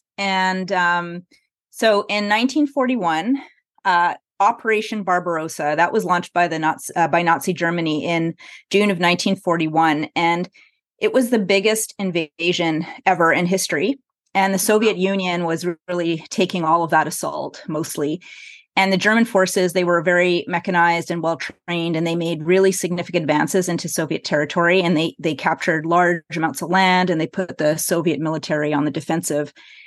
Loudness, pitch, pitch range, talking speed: -19 LUFS, 175 Hz, 165-195 Hz, 160 wpm